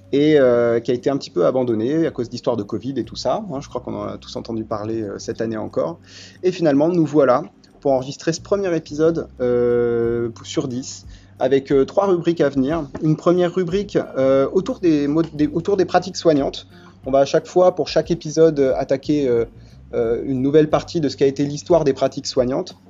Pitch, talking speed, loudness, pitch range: 140 Hz, 210 wpm, -19 LUFS, 120-160 Hz